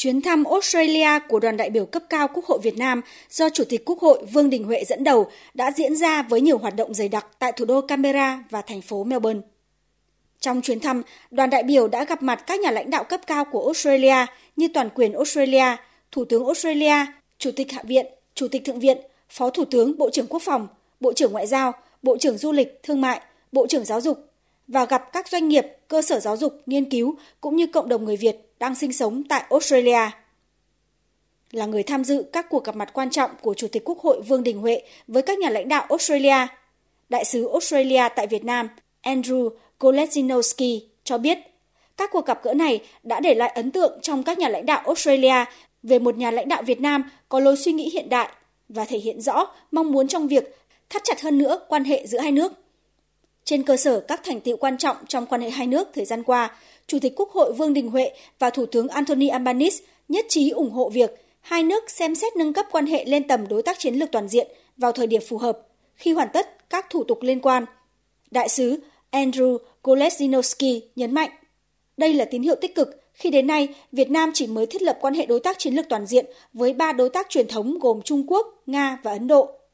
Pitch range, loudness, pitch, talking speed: 245-305 Hz, -21 LUFS, 270 Hz, 225 wpm